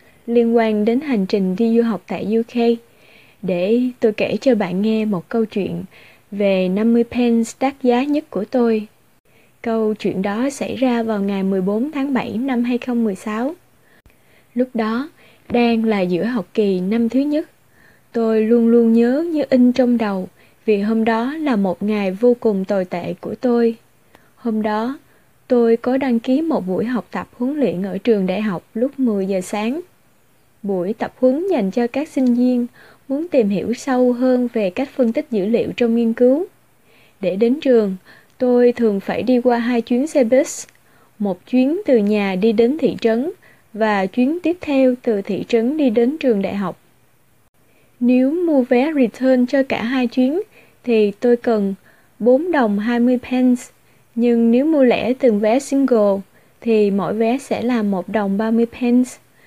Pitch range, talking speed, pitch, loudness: 215-255 Hz, 175 wpm, 235 Hz, -18 LUFS